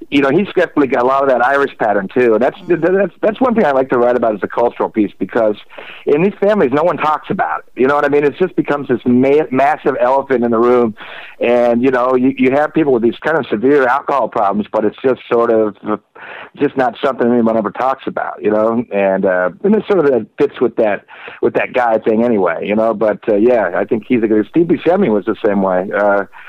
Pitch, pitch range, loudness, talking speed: 125 Hz, 110-145 Hz, -14 LUFS, 245 wpm